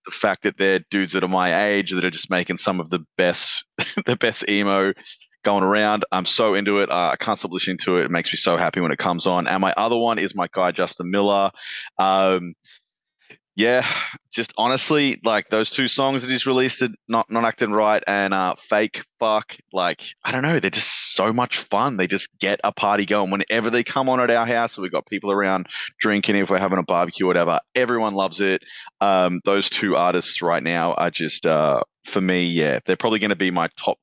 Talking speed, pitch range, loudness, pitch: 220 wpm, 95-115 Hz, -20 LUFS, 100 Hz